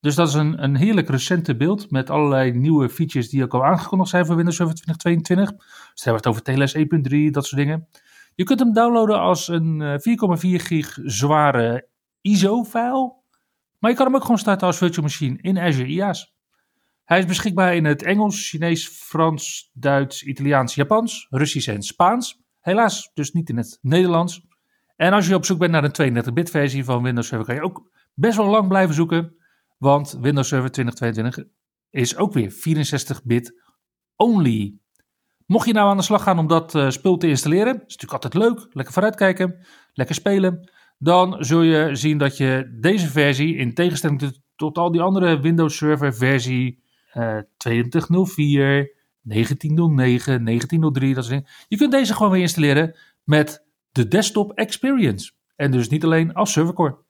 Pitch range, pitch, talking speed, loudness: 135-185 Hz, 160 Hz, 170 wpm, -19 LUFS